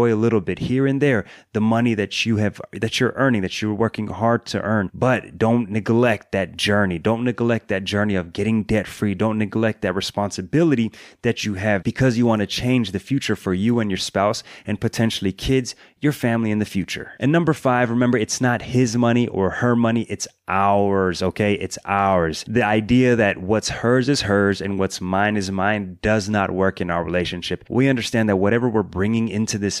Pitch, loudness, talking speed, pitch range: 110 Hz, -20 LUFS, 205 wpm, 100-120 Hz